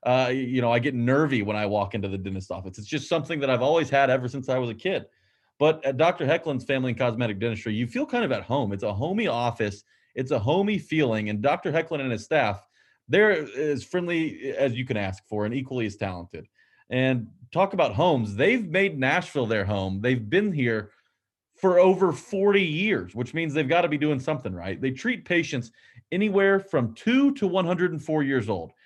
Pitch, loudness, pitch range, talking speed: 135 Hz, -25 LUFS, 115-170 Hz, 210 wpm